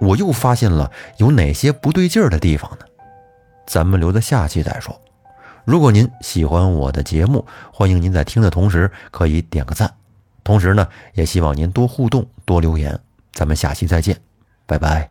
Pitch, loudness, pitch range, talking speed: 95 Hz, -17 LUFS, 80-115 Hz, 260 characters per minute